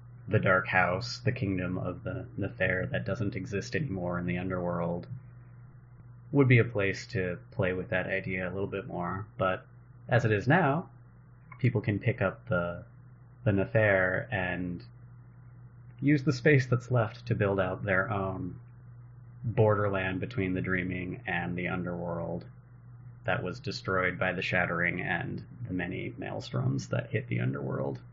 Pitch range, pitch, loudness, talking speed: 95-125 Hz, 105 Hz, -30 LUFS, 150 wpm